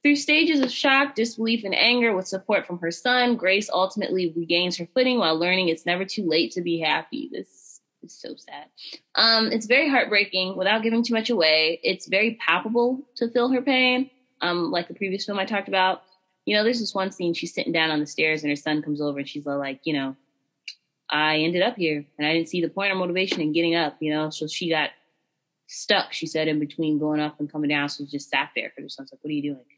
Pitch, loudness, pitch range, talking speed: 180 Hz, -23 LUFS, 155-225 Hz, 240 wpm